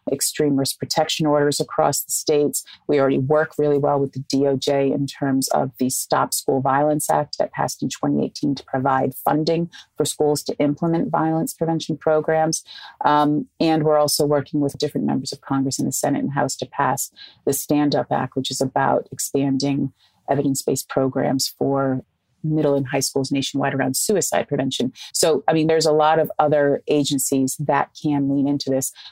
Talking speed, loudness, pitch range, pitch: 180 wpm, -21 LUFS, 135-150 Hz, 140 Hz